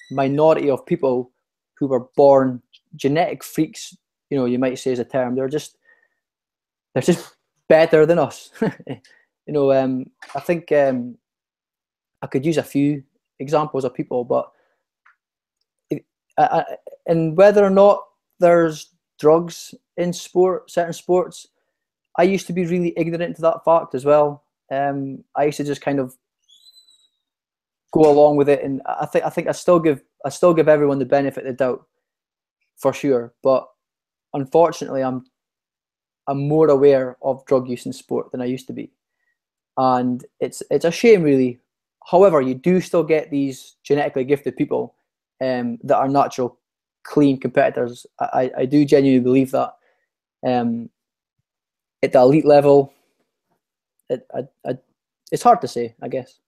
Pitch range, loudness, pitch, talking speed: 130-170 Hz, -19 LUFS, 145 Hz, 160 wpm